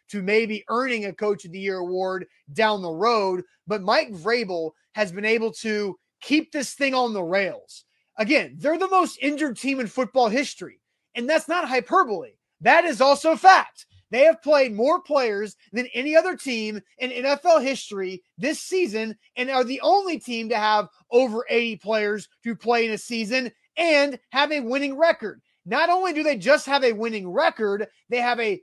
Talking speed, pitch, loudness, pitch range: 185 wpm, 245 Hz, -22 LUFS, 210-290 Hz